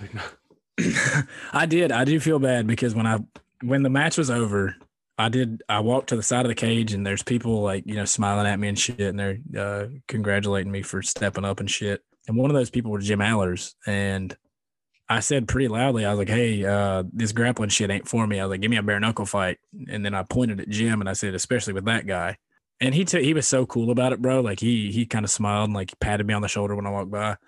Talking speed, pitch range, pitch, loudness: 260 wpm, 100-125 Hz, 110 Hz, -24 LUFS